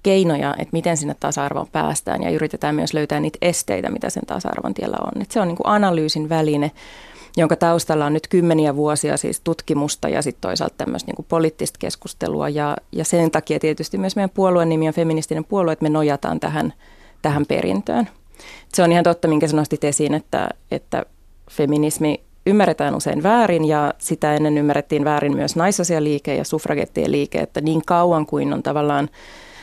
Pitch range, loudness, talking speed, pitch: 150-170 Hz, -20 LUFS, 175 wpm, 160 Hz